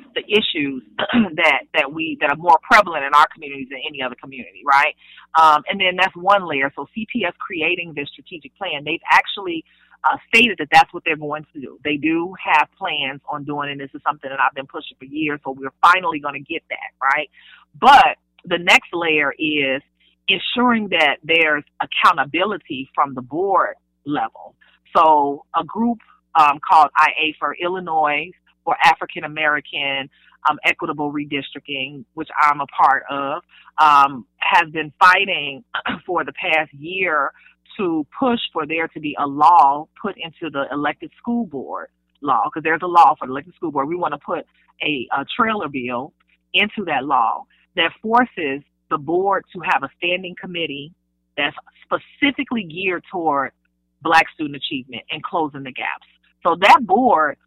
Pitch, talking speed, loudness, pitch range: 160 Hz, 170 wpm, -18 LUFS, 145-185 Hz